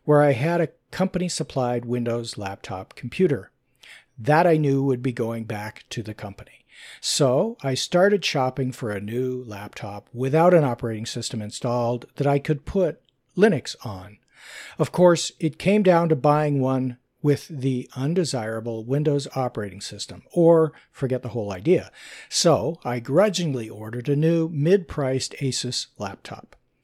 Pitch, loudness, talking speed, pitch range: 130 Hz, -23 LUFS, 150 wpm, 120-155 Hz